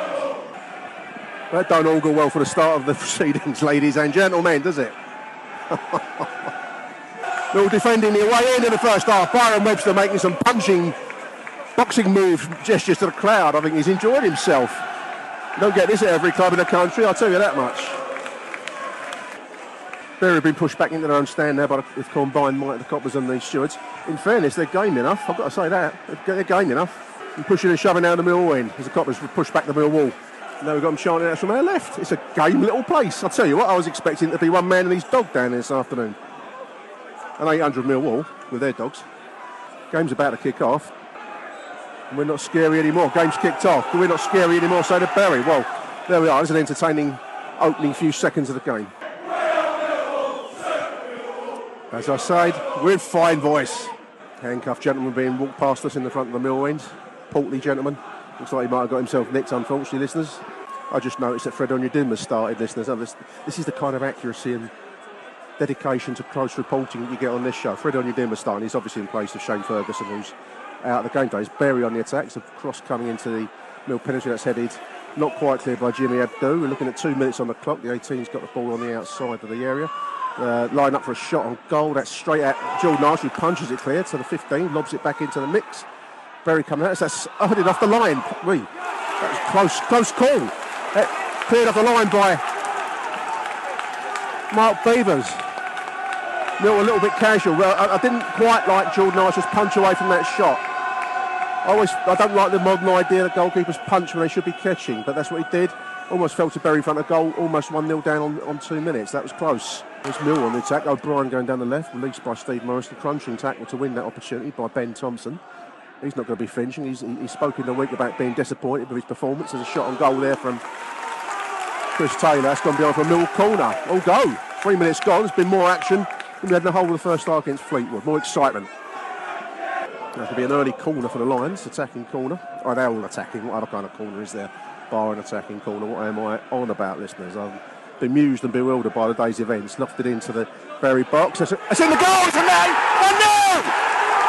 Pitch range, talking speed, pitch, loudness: 130-190 Hz, 220 wpm, 155 Hz, -21 LUFS